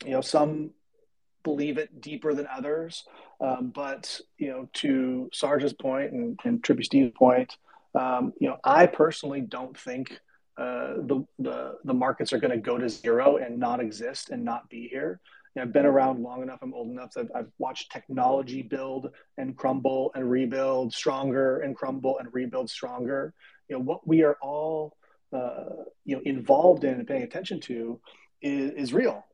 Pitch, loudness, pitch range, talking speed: 140 Hz, -27 LUFS, 130-155 Hz, 185 wpm